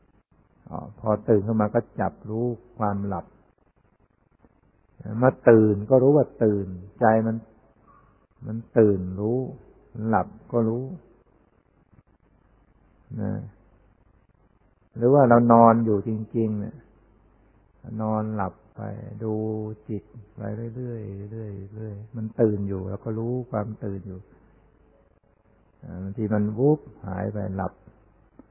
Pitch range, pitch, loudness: 105-115 Hz, 110 Hz, -24 LUFS